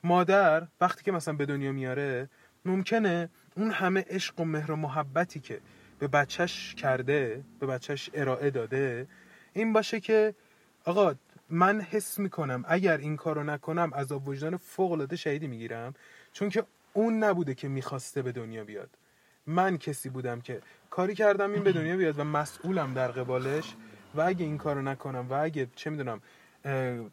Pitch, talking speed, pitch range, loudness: 155 Hz, 165 wpm, 135-185 Hz, -30 LUFS